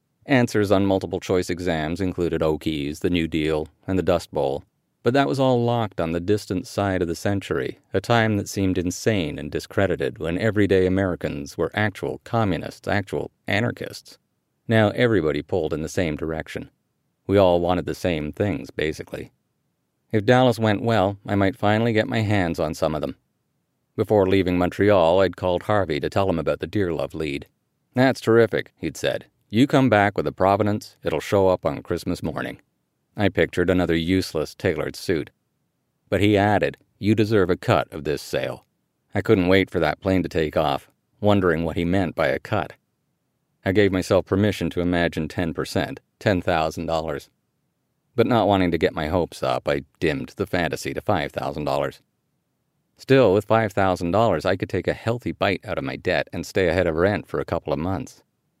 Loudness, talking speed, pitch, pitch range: -22 LUFS, 180 wpm, 95 Hz, 90-110 Hz